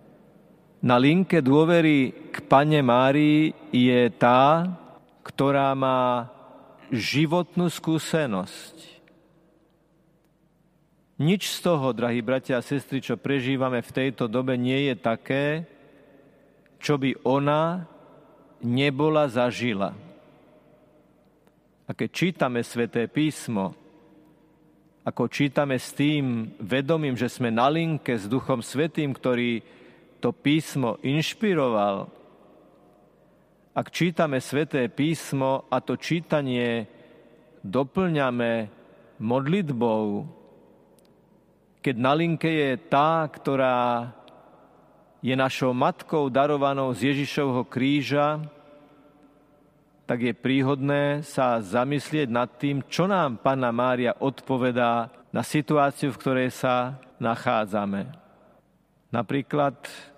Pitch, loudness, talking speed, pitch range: 140 Hz, -24 LUFS, 95 wpm, 125-155 Hz